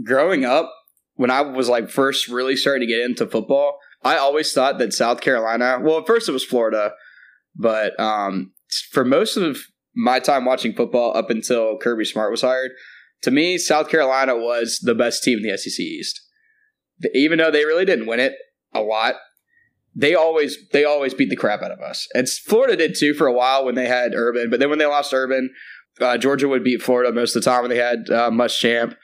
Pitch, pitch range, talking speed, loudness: 130 Hz, 120-150 Hz, 205 wpm, -19 LUFS